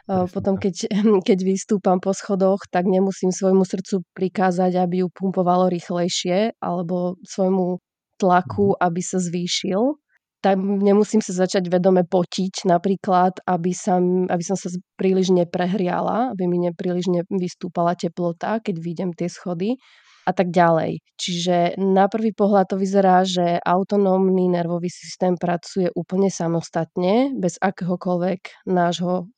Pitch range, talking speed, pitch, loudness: 180-195 Hz, 130 wpm, 185 Hz, -21 LUFS